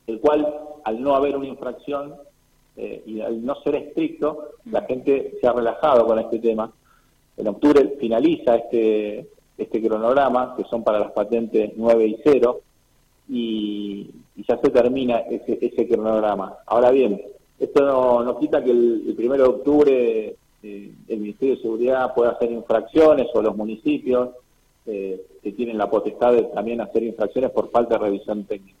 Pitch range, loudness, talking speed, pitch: 110-140 Hz, -21 LUFS, 165 wpm, 120 Hz